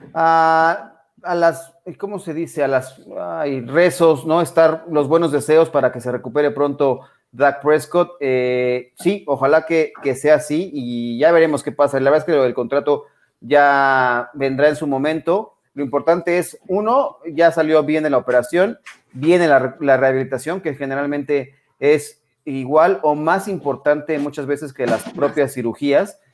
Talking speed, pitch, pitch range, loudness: 165 wpm, 150 Hz, 140-165 Hz, -17 LUFS